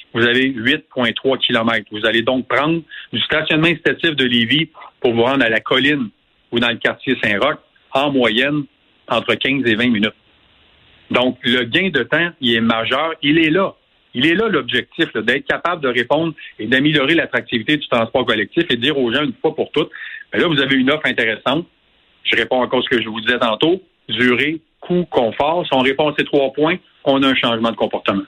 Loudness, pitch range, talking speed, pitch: -16 LUFS, 115-150 Hz, 210 wpm, 130 Hz